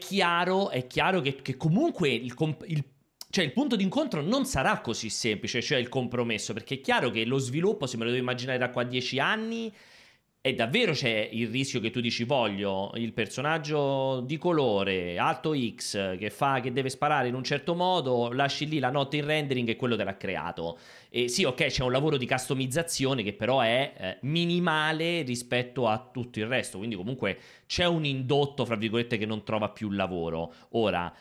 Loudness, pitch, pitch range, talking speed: -28 LUFS, 130 Hz, 115-155 Hz, 195 wpm